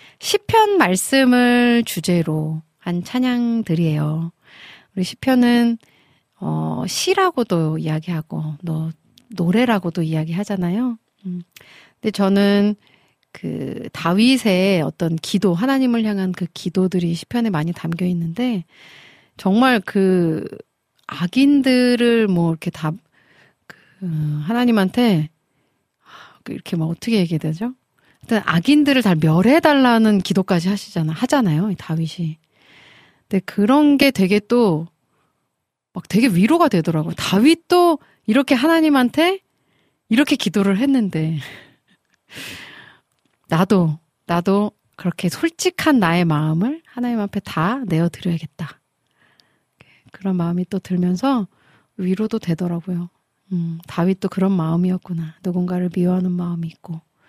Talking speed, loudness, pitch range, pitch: 255 characters per minute, -18 LUFS, 165-235 Hz, 185 Hz